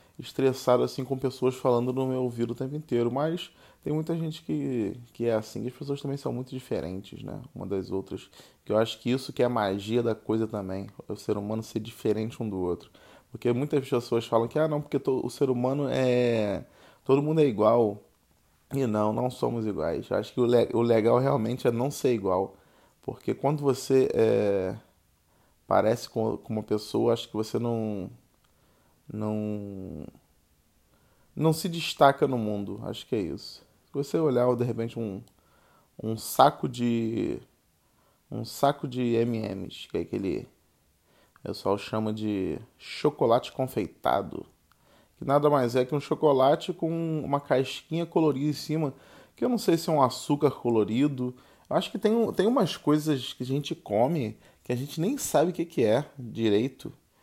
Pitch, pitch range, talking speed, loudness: 125 Hz, 110-140 Hz, 180 wpm, -28 LUFS